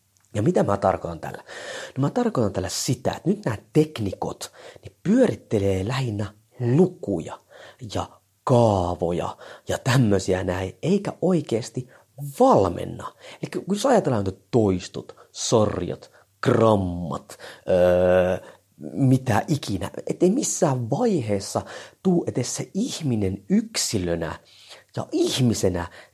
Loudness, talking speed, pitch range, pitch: -23 LUFS, 110 wpm, 100-155 Hz, 115 Hz